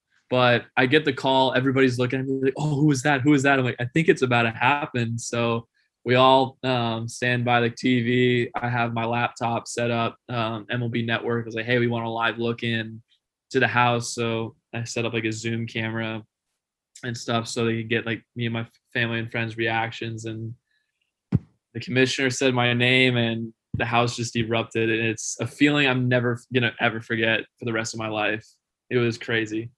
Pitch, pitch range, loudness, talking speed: 120 Hz, 115-125 Hz, -23 LUFS, 210 wpm